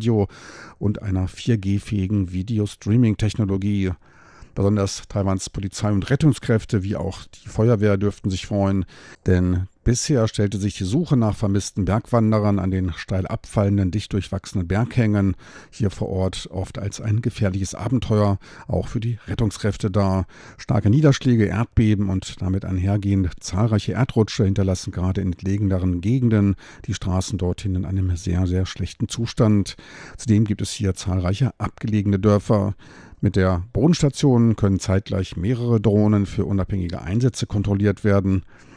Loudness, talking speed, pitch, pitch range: -22 LUFS, 140 wpm, 100 Hz, 95-110 Hz